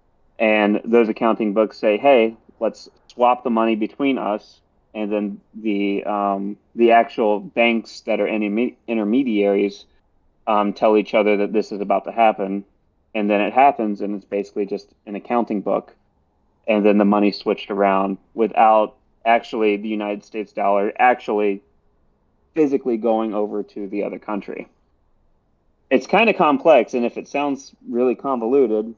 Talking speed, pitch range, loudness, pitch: 155 wpm, 100-115 Hz, -19 LUFS, 105 Hz